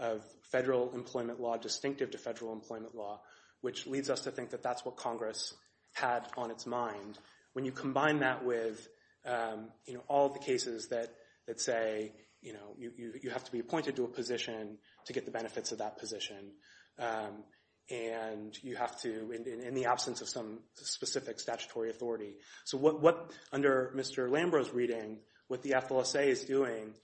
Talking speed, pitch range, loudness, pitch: 185 wpm, 110-130 Hz, -36 LUFS, 120 Hz